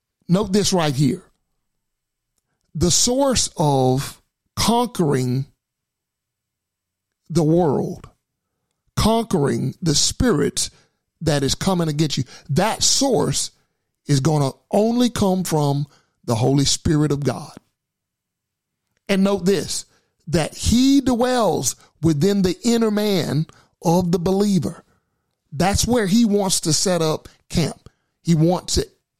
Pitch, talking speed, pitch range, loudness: 170 Hz, 115 wpm, 140-200 Hz, -19 LUFS